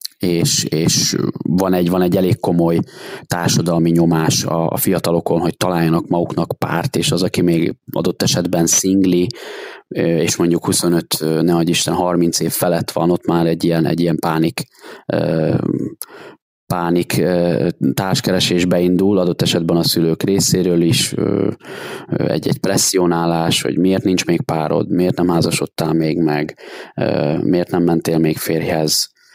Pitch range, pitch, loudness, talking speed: 85-90 Hz, 85 Hz, -16 LUFS, 135 wpm